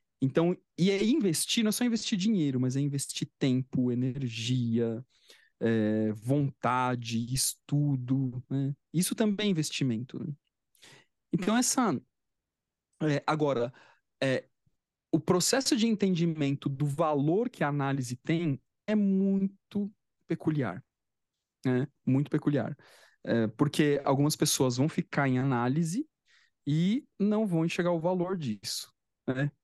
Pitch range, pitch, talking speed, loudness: 130-180 Hz, 145 Hz, 120 wpm, -29 LUFS